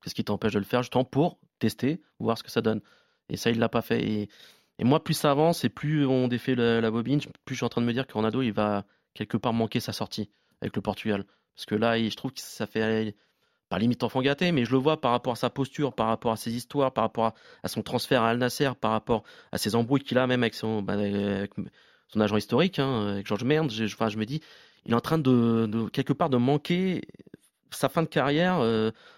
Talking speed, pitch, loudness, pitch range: 265 wpm, 120 Hz, -27 LUFS, 110-135 Hz